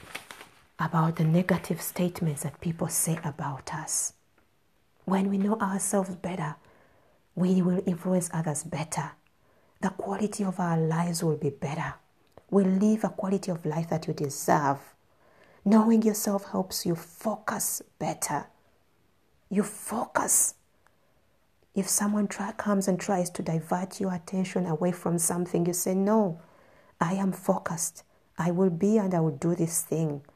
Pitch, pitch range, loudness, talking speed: 180 Hz, 165-195 Hz, -28 LUFS, 140 wpm